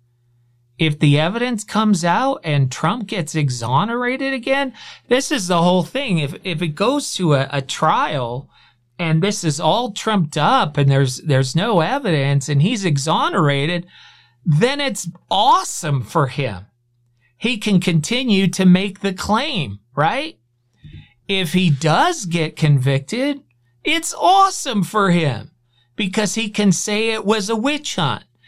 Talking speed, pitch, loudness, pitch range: 145 wpm, 175 Hz, -18 LUFS, 140-220 Hz